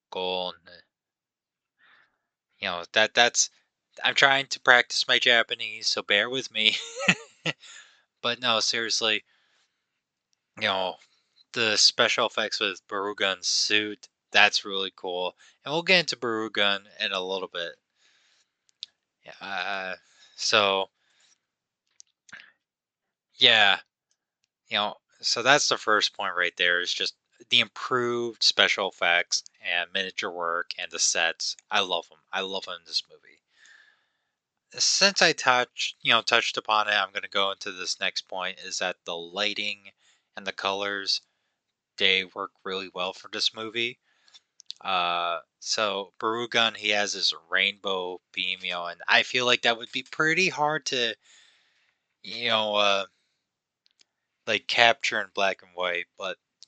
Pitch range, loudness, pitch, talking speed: 95-130 Hz, -24 LUFS, 110 Hz, 140 wpm